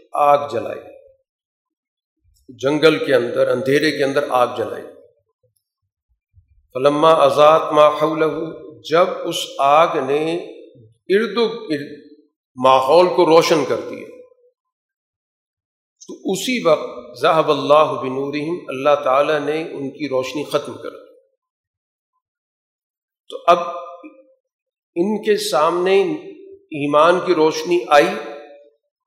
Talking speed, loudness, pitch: 95 wpm, -17 LUFS, 160 Hz